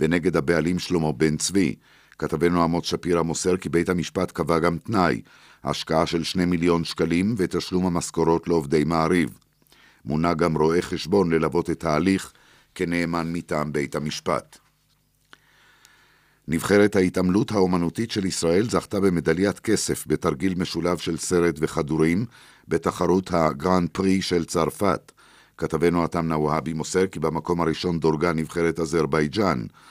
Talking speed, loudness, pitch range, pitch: 125 wpm, -23 LUFS, 80-90 Hz, 85 Hz